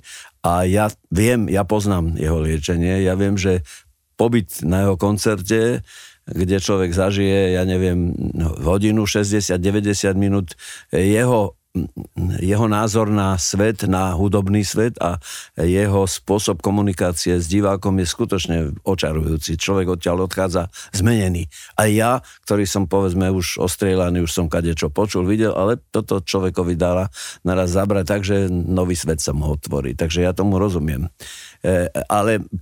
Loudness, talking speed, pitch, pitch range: -19 LUFS, 135 wpm, 95 Hz, 90-100 Hz